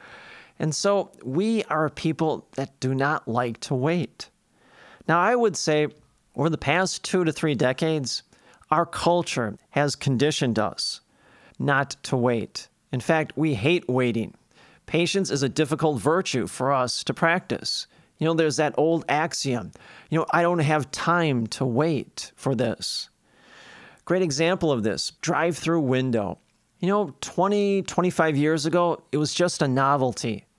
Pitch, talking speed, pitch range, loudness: 155 Hz, 150 wpm, 135-170 Hz, -24 LUFS